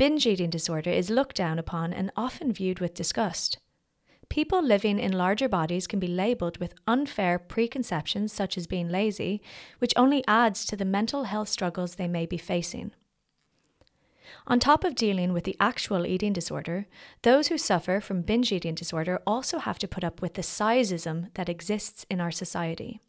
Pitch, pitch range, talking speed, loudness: 195 Hz, 175-230 Hz, 175 wpm, -27 LUFS